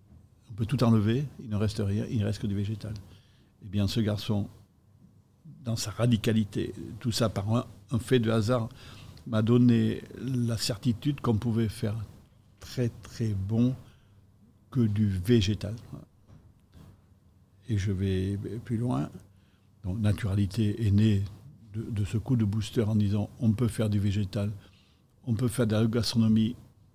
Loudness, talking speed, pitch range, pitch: -29 LUFS, 155 wpm, 100-115 Hz, 110 Hz